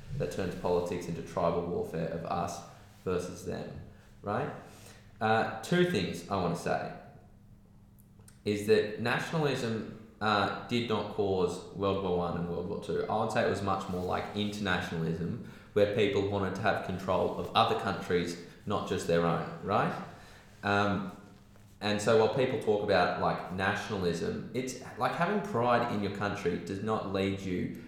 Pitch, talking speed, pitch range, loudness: 100 Hz, 160 wpm, 90-110 Hz, -32 LUFS